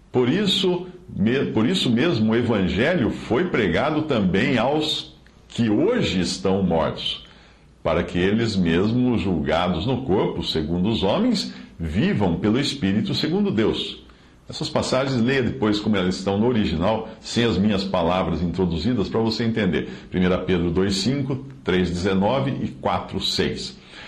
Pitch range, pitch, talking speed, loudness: 90-125 Hz, 105 Hz, 130 wpm, -22 LUFS